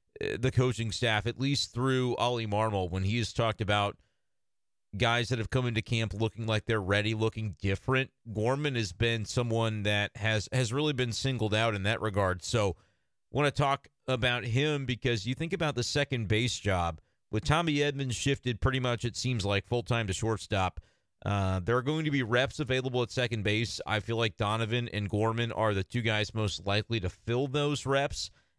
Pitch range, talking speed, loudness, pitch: 105-130 Hz, 195 wpm, -30 LUFS, 115 Hz